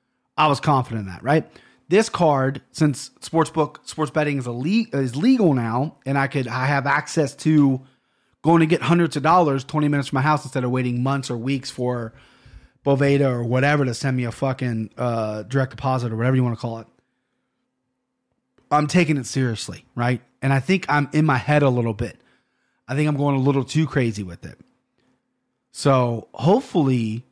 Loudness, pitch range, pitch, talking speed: -21 LUFS, 125-150 Hz, 135 Hz, 195 wpm